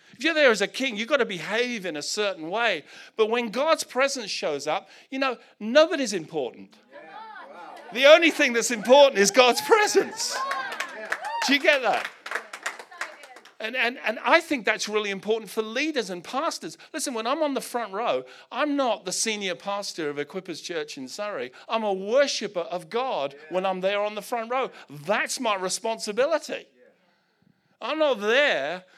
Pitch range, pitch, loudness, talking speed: 205-285 Hz, 235 Hz, -24 LUFS, 170 wpm